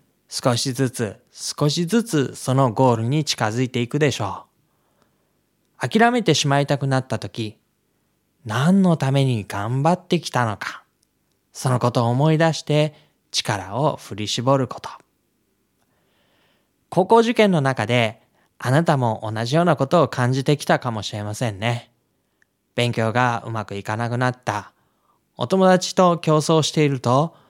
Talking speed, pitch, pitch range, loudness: 270 characters per minute, 130 Hz, 115-155 Hz, -20 LUFS